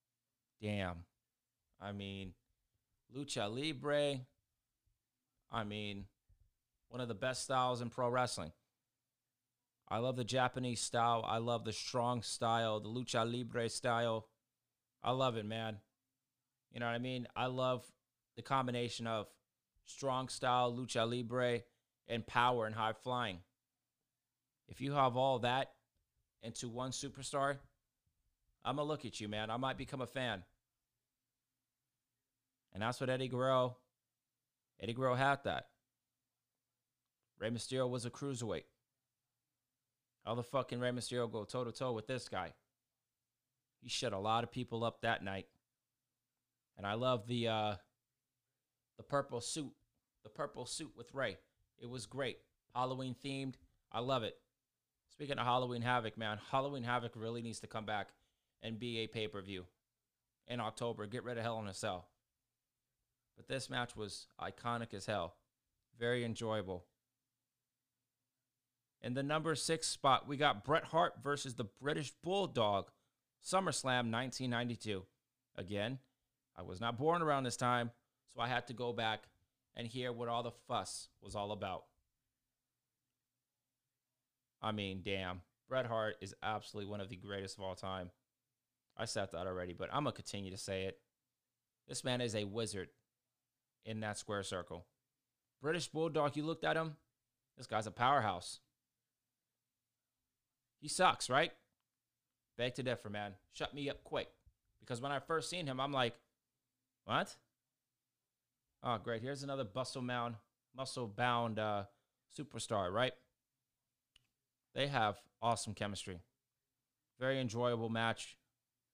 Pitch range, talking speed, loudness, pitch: 115-130 Hz, 145 wpm, -40 LUFS, 125 Hz